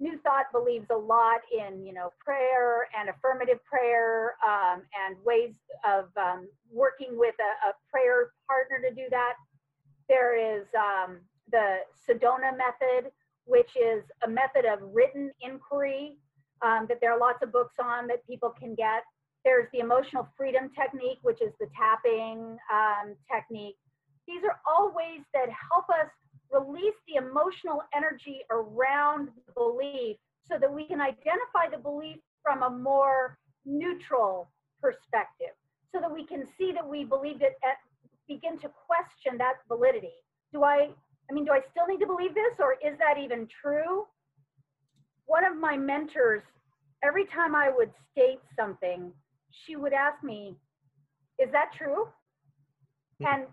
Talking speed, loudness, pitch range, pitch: 155 wpm, -28 LUFS, 220-300 Hz, 260 Hz